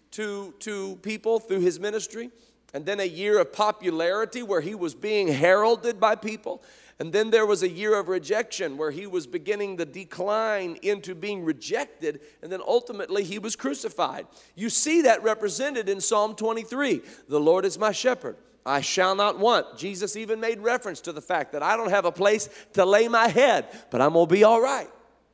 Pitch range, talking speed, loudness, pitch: 190-225 Hz, 190 wpm, -25 LUFS, 210 Hz